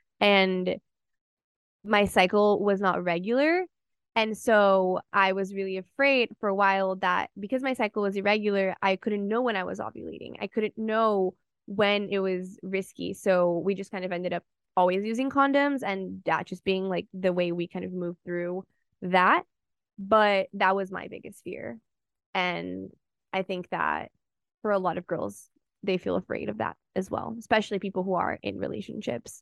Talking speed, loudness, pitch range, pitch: 175 wpm, -27 LUFS, 185-210 Hz, 195 Hz